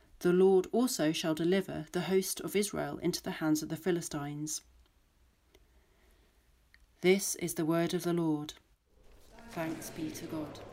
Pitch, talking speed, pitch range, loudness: 165 Hz, 145 wpm, 150-180 Hz, -32 LUFS